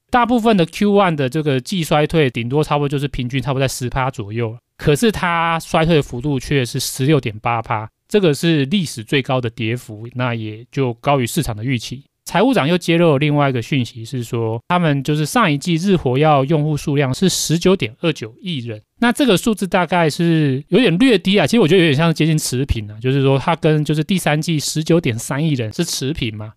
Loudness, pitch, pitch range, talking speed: -17 LUFS, 145 Hz, 125-165 Hz, 330 characters per minute